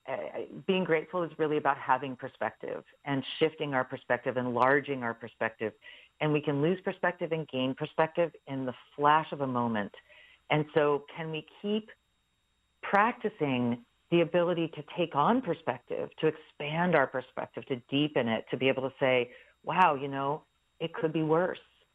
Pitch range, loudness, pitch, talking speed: 130-165 Hz, -31 LUFS, 150 Hz, 165 wpm